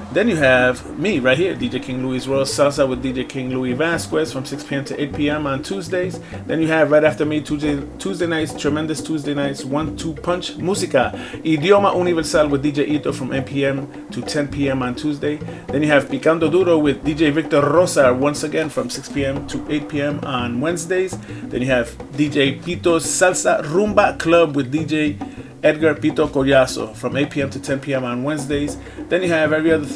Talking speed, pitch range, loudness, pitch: 200 wpm, 135-160 Hz, -19 LUFS, 150 Hz